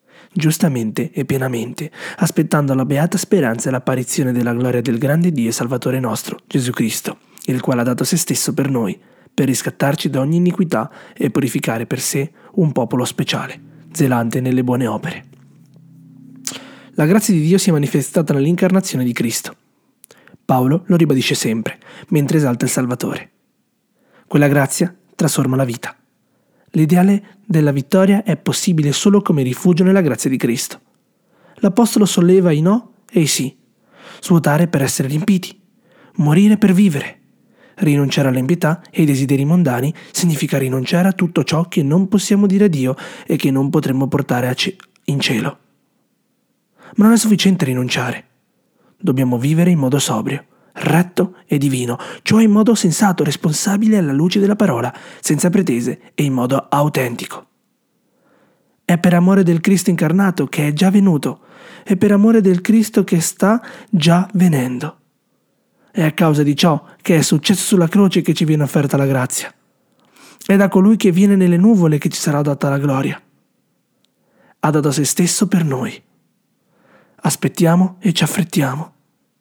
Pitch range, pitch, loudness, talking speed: 140-195 Hz, 170 Hz, -16 LUFS, 155 wpm